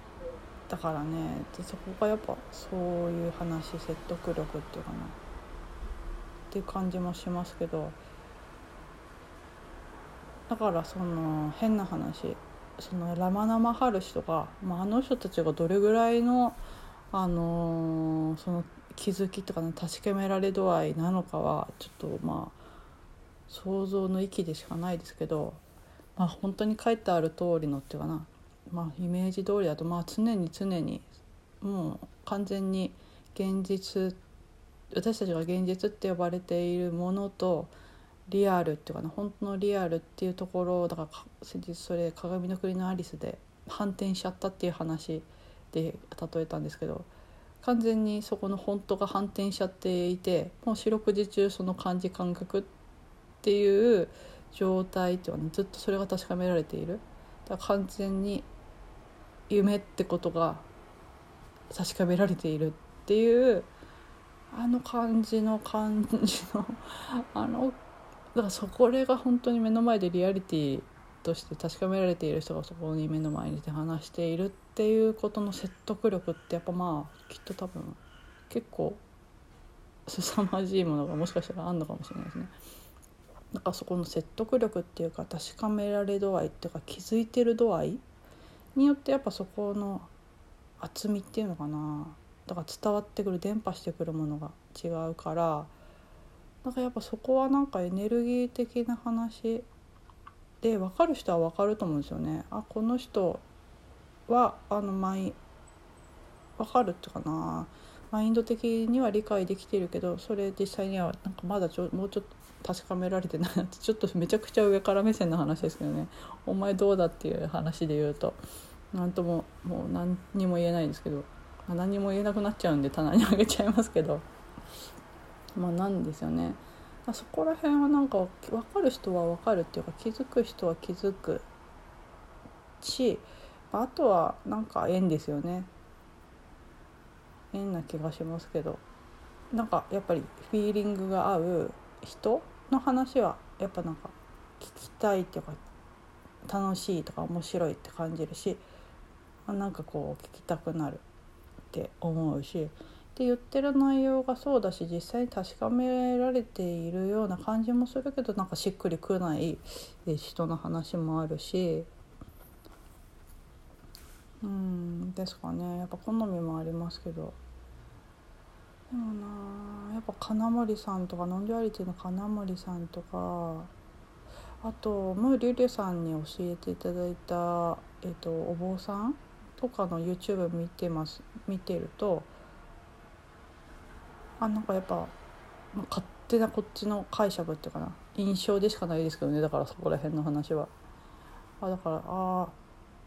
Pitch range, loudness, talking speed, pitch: 165-210 Hz, -31 LUFS, 305 characters per minute, 185 Hz